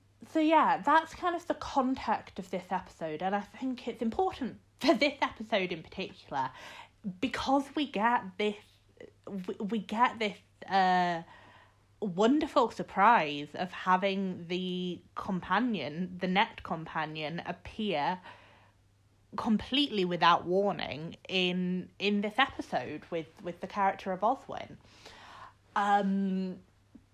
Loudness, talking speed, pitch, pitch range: -31 LUFS, 115 wpm, 195 Hz, 180-235 Hz